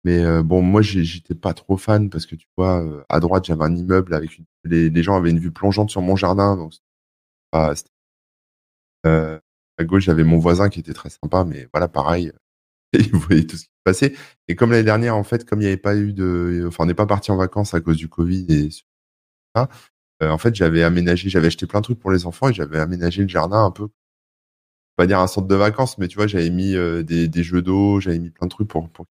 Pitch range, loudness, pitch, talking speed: 80-95 Hz, -19 LUFS, 85 Hz, 245 wpm